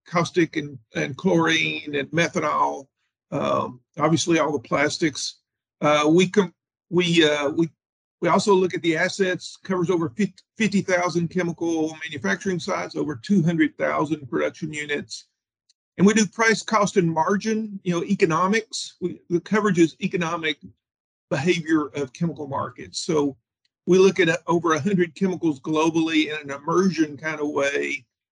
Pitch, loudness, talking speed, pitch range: 165 Hz, -23 LUFS, 140 wpm, 150-185 Hz